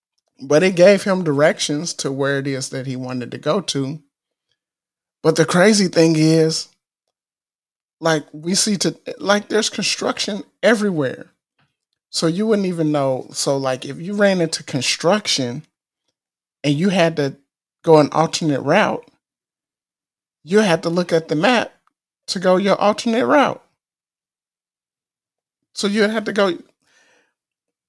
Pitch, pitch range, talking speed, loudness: 165 Hz, 145-200 Hz, 140 wpm, -18 LUFS